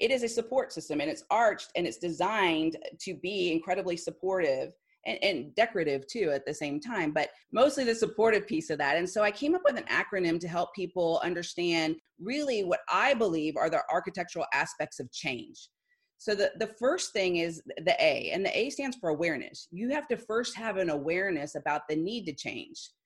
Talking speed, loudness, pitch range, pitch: 205 wpm, -30 LUFS, 165-255 Hz, 190 Hz